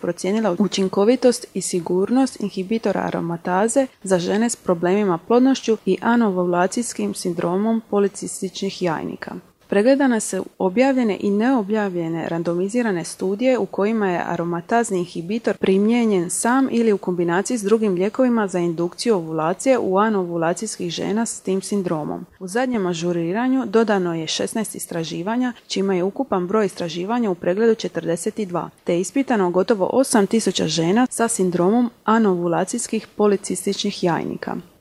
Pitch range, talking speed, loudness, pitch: 180-225 Hz, 120 wpm, -20 LUFS, 200 Hz